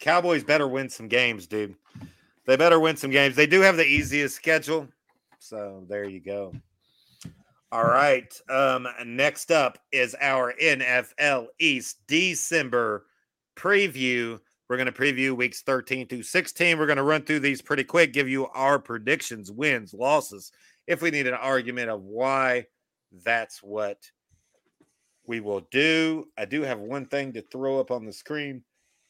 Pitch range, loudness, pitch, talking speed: 115-150 Hz, -24 LUFS, 130 Hz, 160 wpm